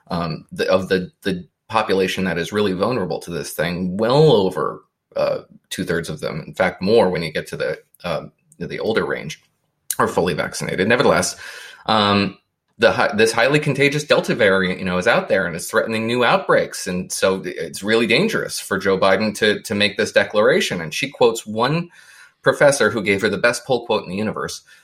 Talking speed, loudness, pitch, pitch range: 195 wpm, -19 LUFS, 105 Hz, 95-125 Hz